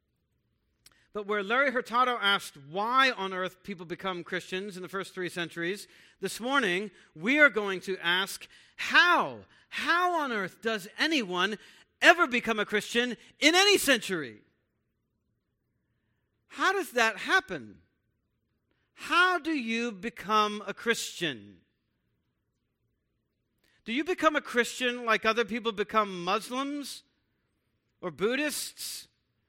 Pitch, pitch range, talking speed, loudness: 210 Hz, 180-260 Hz, 120 wpm, -27 LUFS